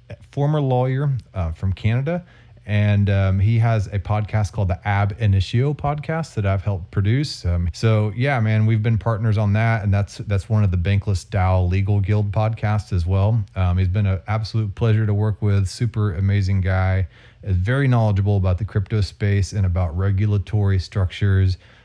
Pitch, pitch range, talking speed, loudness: 105 Hz, 95-115 Hz, 180 wpm, -21 LUFS